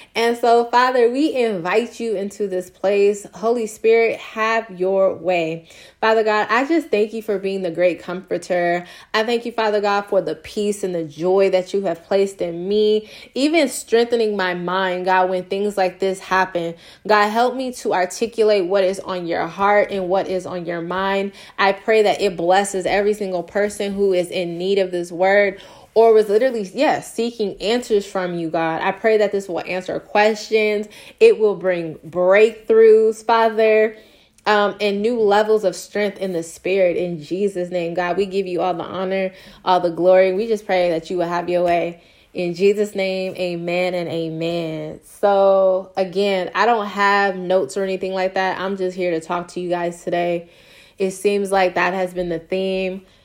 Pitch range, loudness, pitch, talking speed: 180-210 Hz, -19 LUFS, 195 Hz, 190 wpm